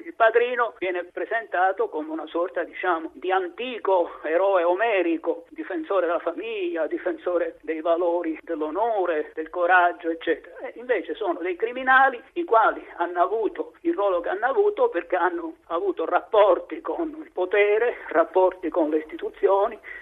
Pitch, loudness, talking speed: 195 Hz, -24 LUFS, 140 wpm